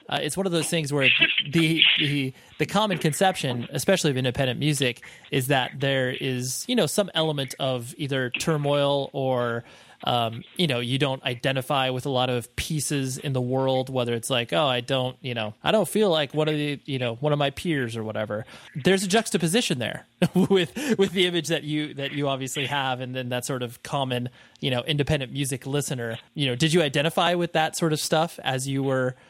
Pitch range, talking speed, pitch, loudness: 130-160 Hz, 210 wpm, 140 Hz, -24 LUFS